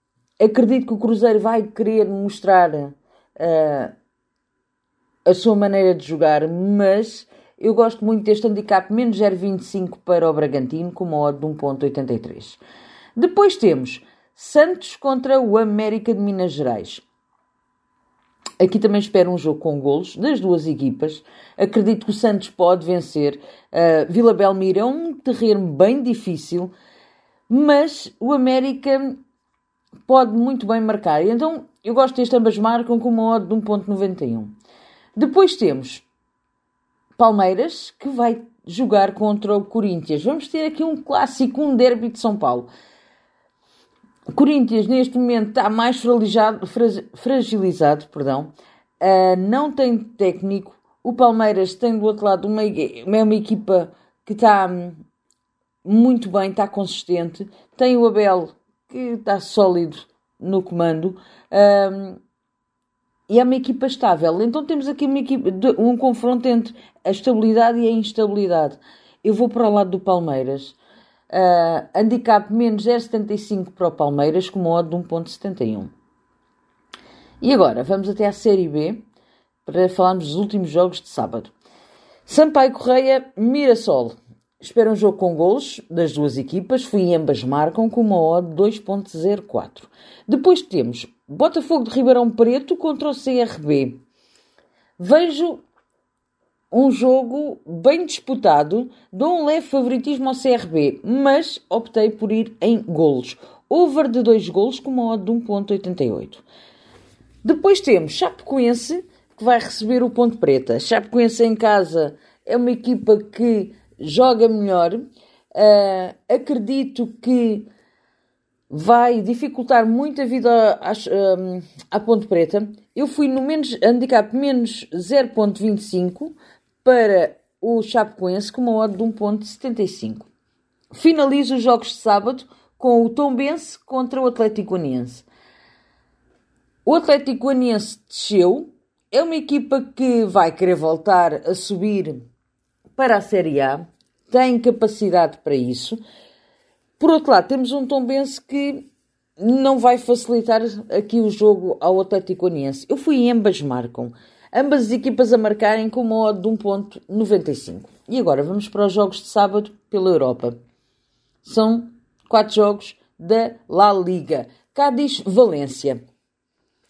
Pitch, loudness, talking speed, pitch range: 215 Hz, -18 LUFS, 130 wpm, 185-250 Hz